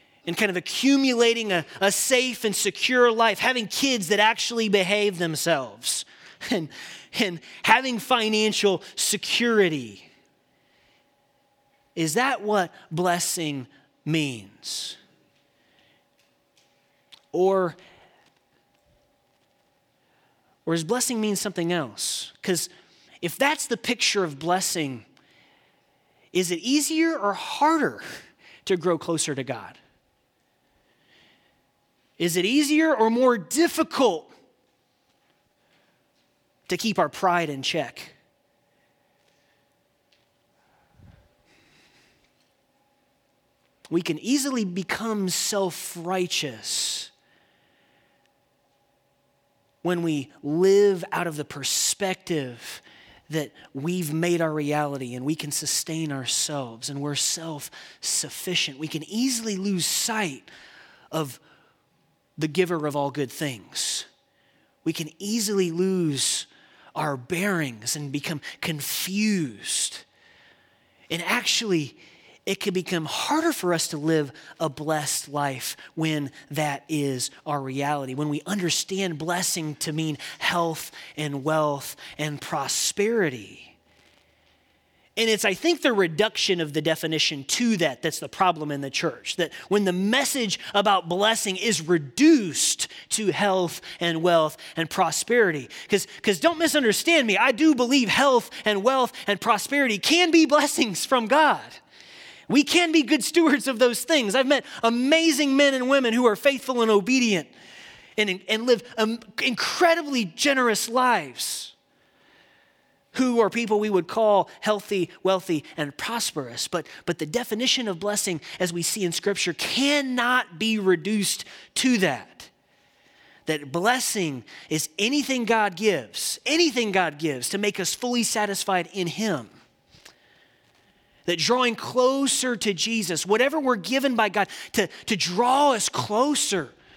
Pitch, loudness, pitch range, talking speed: 190 Hz, -24 LUFS, 160-235 Hz, 120 wpm